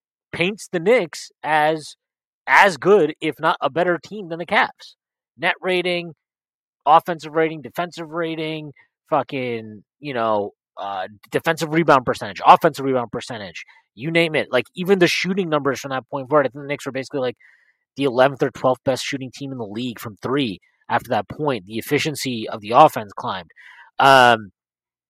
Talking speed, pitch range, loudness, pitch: 165 wpm, 125-165 Hz, -20 LUFS, 145 Hz